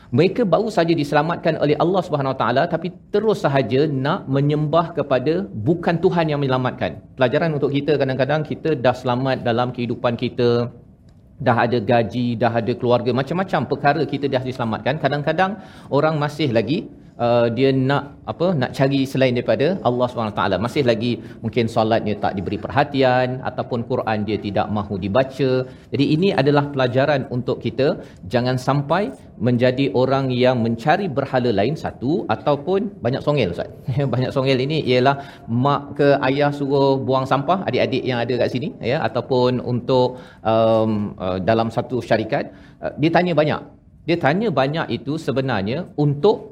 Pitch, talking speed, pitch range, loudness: 130 Hz, 155 wpm, 120-150 Hz, -20 LUFS